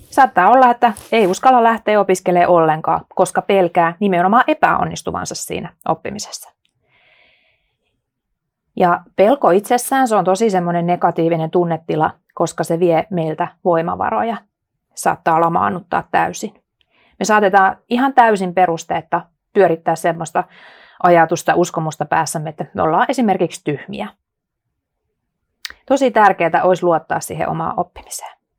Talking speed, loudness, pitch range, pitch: 110 wpm, -16 LUFS, 170-215 Hz, 180 Hz